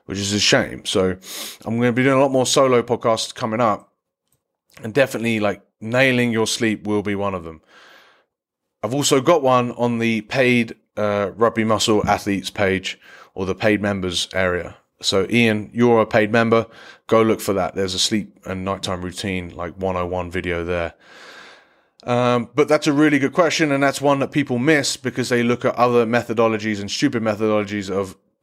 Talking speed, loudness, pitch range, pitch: 185 wpm, -19 LUFS, 100-120 Hz, 110 Hz